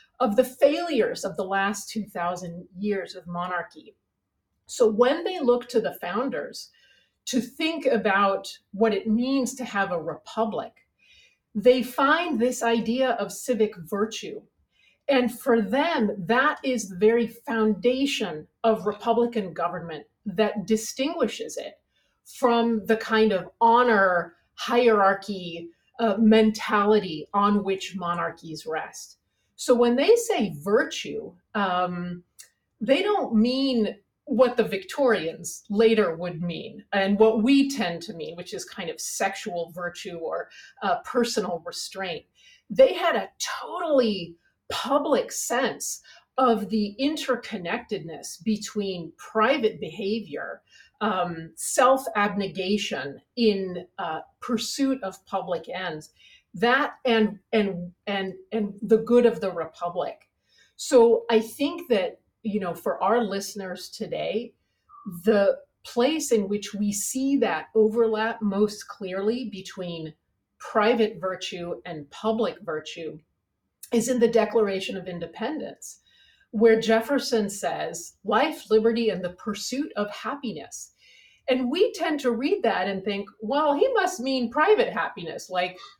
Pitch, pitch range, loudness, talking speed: 220 Hz, 190-250 Hz, -25 LUFS, 125 wpm